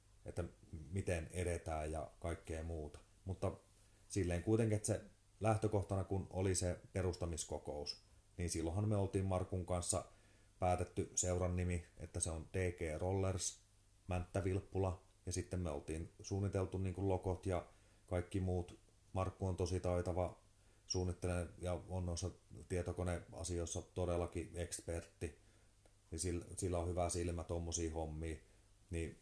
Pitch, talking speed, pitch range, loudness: 90 Hz, 125 wpm, 85-100 Hz, -42 LUFS